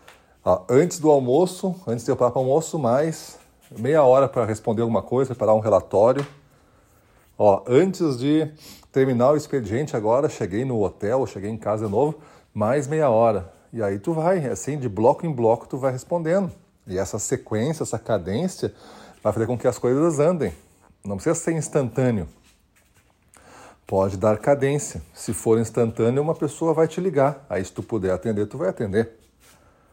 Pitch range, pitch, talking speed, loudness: 110-150 Hz, 125 Hz, 170 wpm, -22 LUFS